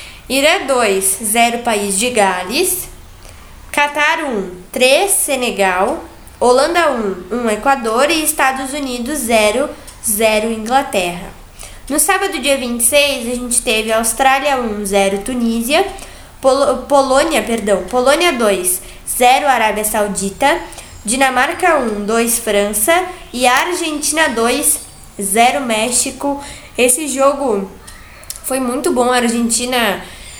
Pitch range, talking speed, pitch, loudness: 220-280 Hz, 115 wpm, 250 Hz, -14 LUFS